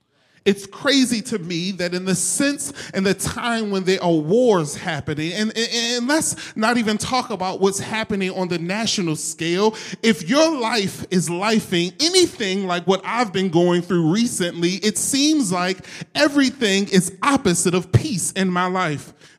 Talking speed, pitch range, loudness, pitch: 165 wpm, 175-230 Hz, -20 LUFS, 195 Hz